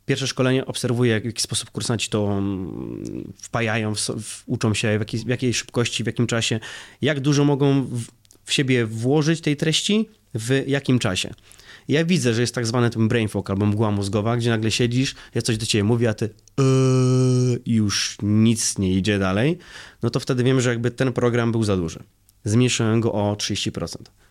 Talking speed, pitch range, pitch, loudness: 190 wpm, 105-130 Hz, 120 Hz, -21 LUFS